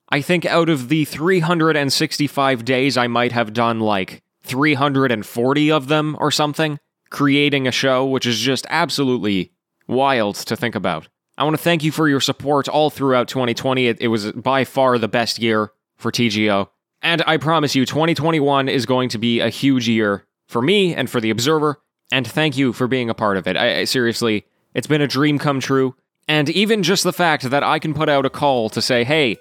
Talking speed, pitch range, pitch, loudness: 205 wpm, 120-155 Hz, 135 Hz, -18 LUFS